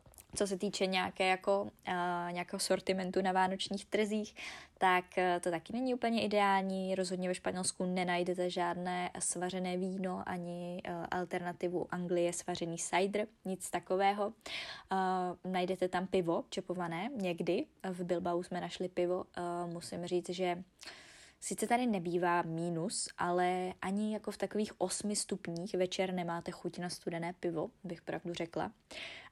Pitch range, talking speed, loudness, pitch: 175-195 Hz, 140 wpm, -36 LUFS, 185 Hz